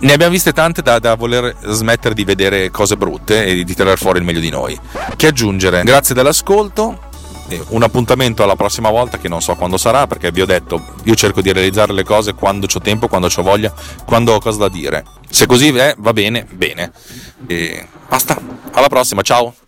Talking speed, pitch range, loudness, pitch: 200 wpm, 95-120 Hz, -13 LUFS, 105 Hz